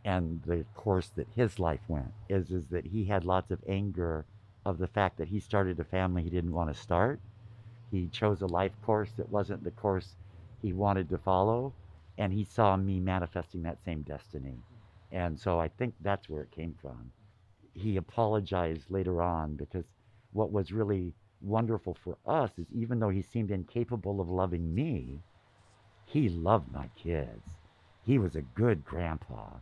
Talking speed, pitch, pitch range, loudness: 175 wpm, 95 Hz, 85-105 Hz, -33 LUFS